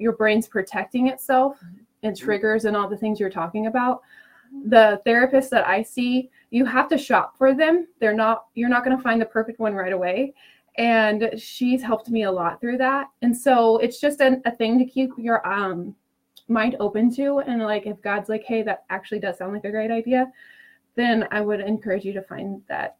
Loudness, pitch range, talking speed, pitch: -22 LUFS, 210-255 Hz, 210 wpm, 225 Hz